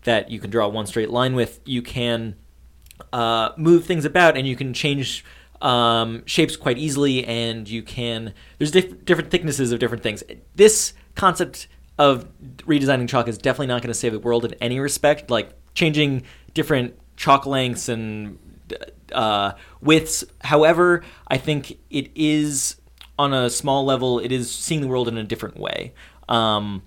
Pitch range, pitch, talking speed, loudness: 115-145 Hz, 125 Hz, 170 wpm, -21 LUFS